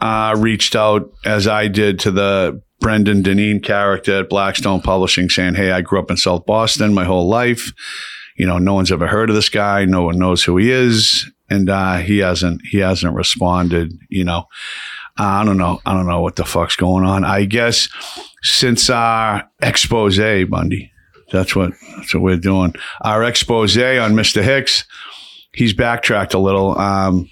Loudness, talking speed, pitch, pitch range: -15 LUFS, 180 wpm, 100 Hz, 90-110 Hz